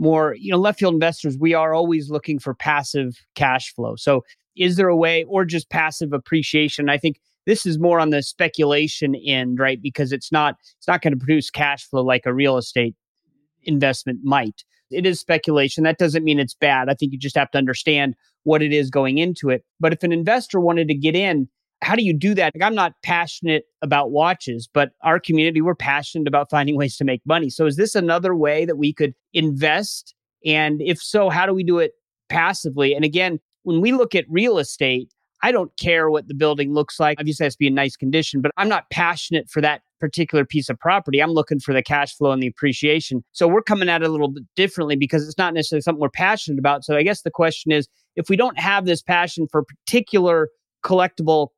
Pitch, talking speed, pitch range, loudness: 155 Hz, 225 wpm, 145-170 Hz, -19 LUFS